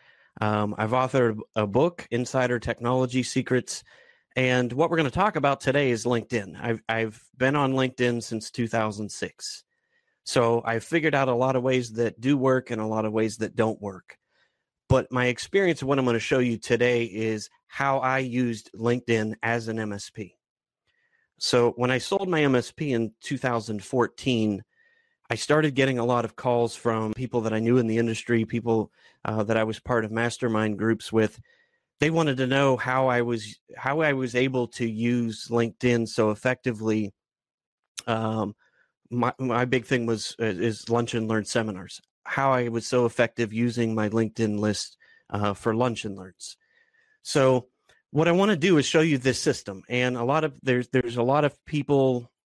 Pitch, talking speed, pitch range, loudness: 120 Hz, 180 wpm, 110-130 Hz, -25 LUFS